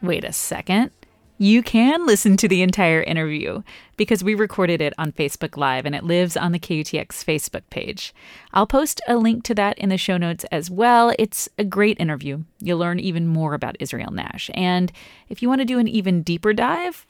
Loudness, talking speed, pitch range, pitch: -20 LUFS, 205 wpm, 165-220 Hz, 185 Hz